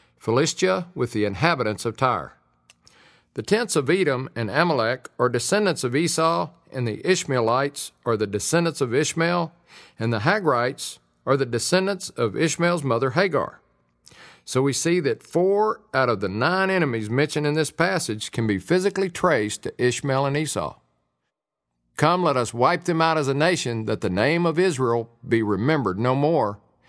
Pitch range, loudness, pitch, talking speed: 115-170 Hz, -23 LUFS, 135 Hz, 165 wpm